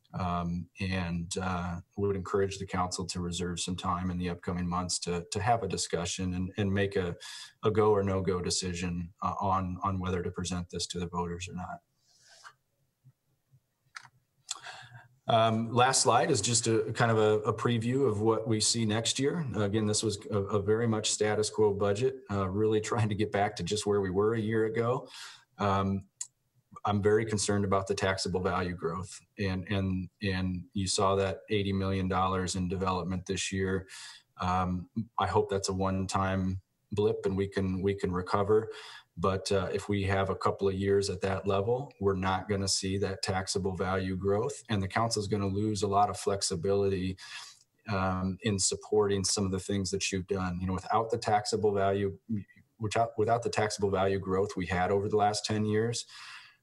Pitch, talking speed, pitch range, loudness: 100 Hz, 190 wpm, 95-105 Hz, -30 LUFS